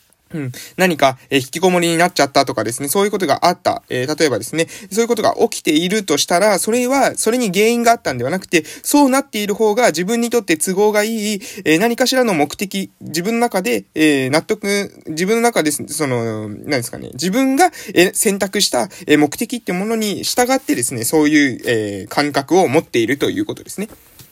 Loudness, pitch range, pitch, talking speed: -16 LUFS, 150-230 Hz, 190 Hz, 385 characters per minute